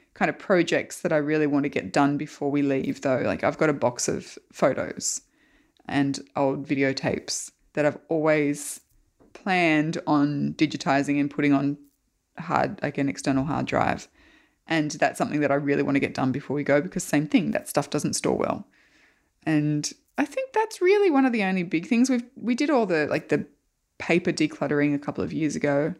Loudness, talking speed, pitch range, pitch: -25 LUFS, 195 wpm, 140-170 Hz, 150 Hz